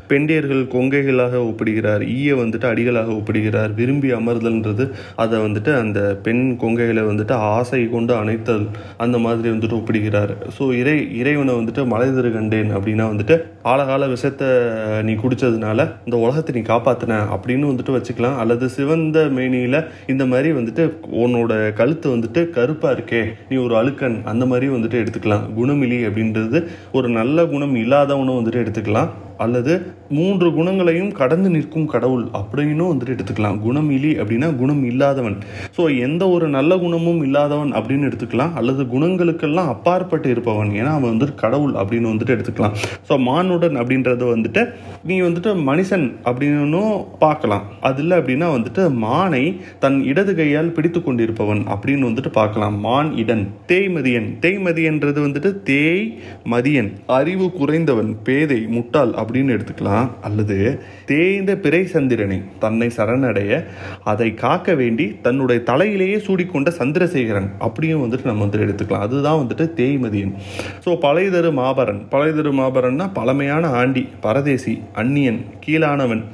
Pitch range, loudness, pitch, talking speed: 110-145 Hz, -18 LUFS, 125 Hz, 130 wpm